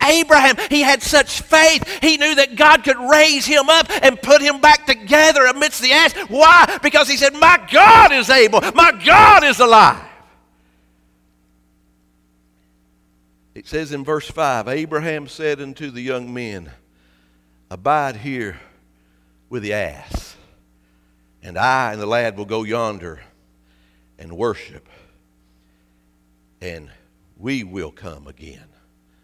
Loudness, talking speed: -12 LUFS, 130 wpm